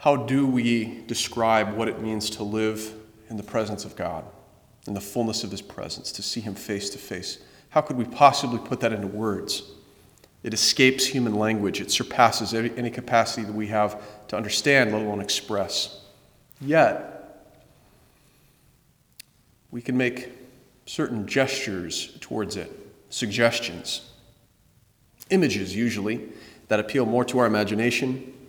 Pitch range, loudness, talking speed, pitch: 105-125 Hz, -25 LUFS, 140 wpm, 115 Hz